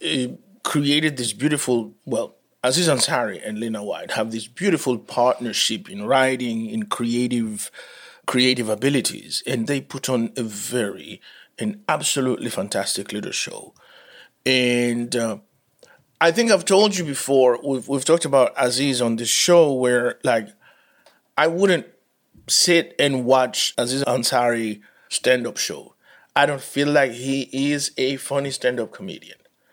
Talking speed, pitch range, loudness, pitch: 135 wpm, 120-145 Hz, -21 LUFS, 130 Hz